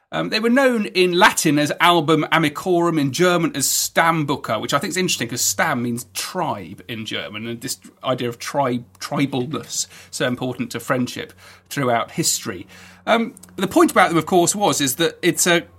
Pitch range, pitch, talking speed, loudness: 125-175 Hz, 155 Hz, 180 wpm, -19 LUFS